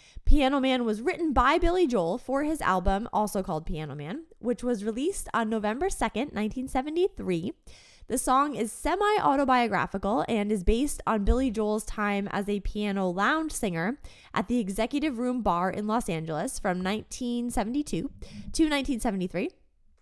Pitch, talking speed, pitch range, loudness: 230 Hz, 150 wpm, 200-270 Hz, -28 LUFS